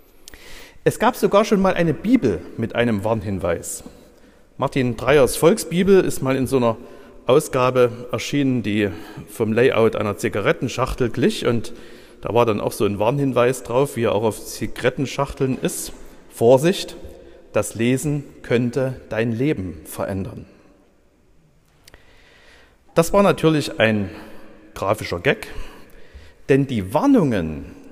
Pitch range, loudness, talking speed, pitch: 110-150 Hz, -20 LUFS, 125 wpm, 130 Hz